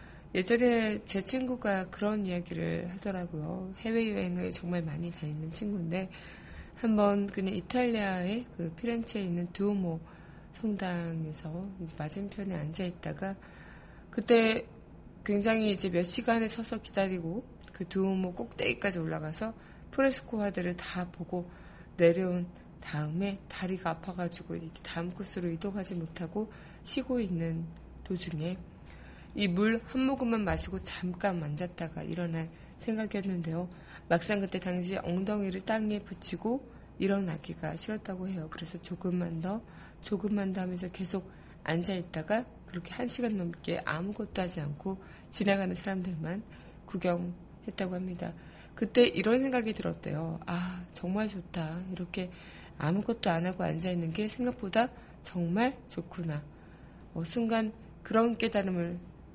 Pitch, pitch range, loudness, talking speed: 185 Hz, 170-210 Hz, -33 LUFS, 300 characters per minute